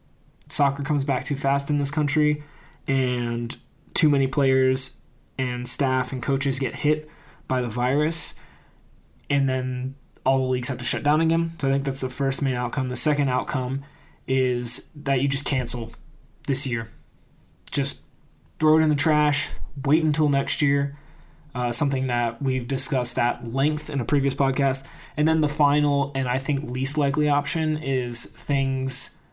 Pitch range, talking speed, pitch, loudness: 130-145 Hz, 170 wpm, 135 Hz, -23 LUFS